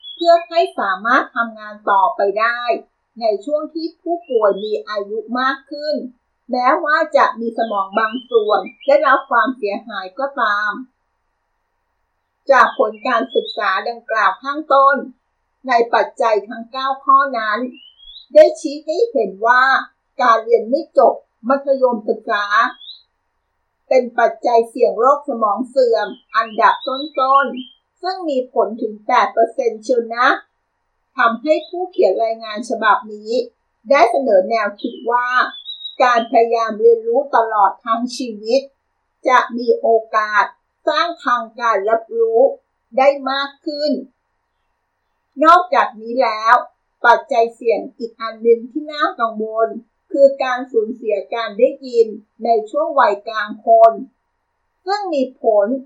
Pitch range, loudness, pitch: 225-285 Hz, -16 LUFS, 250 Hz